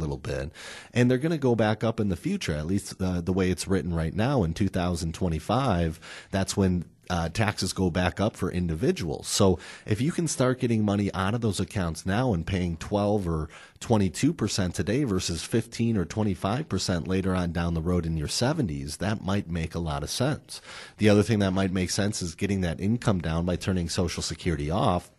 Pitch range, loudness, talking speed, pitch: 85-105 Hz, -27 LUFS, 205 wpm, 95 Hz